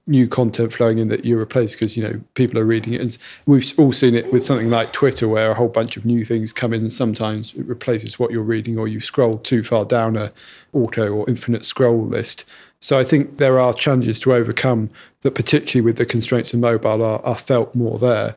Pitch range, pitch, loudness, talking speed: 110-125 Hz, 120 Hz, -18 LUFS, 230 wpm